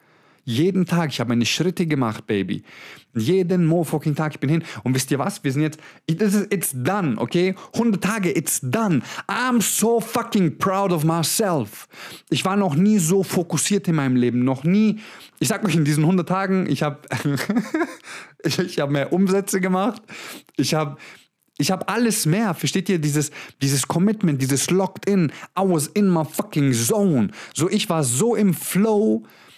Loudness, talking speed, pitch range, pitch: -21 LUFS, 180 wpm, 150-195 Hz, 175 Hz